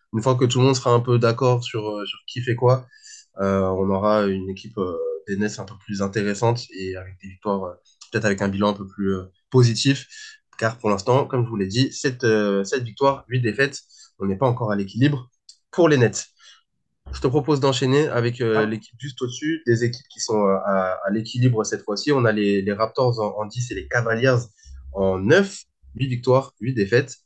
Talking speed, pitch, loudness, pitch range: 220 wpm, 115 Hz, -22 LUFS, 100-130 Hz